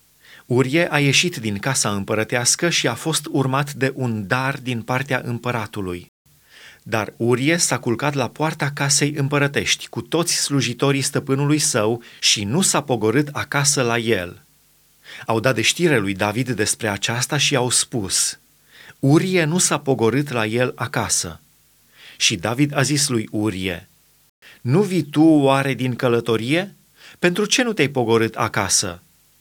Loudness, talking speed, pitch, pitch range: -19 LUFS, 145 wpm, 135 Hz, 115-150 Hz